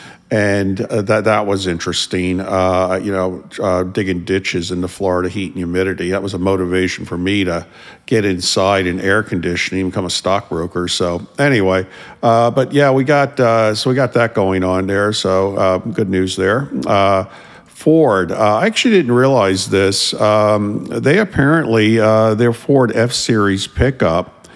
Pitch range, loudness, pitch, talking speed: 95-110 Hz, -15 LUFS, 100 Hz, 170 wpm